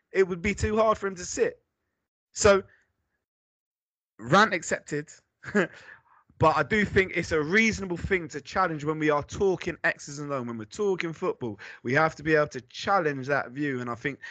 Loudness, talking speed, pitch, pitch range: -26 LUFS, 190 wpm, 165 Hz, 145-195 Hz